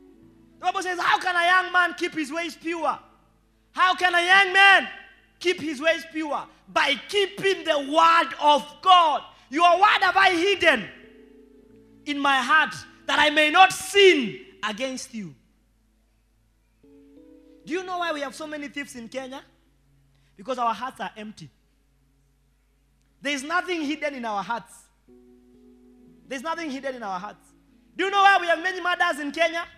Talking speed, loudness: 165 wpm, -21 LUFS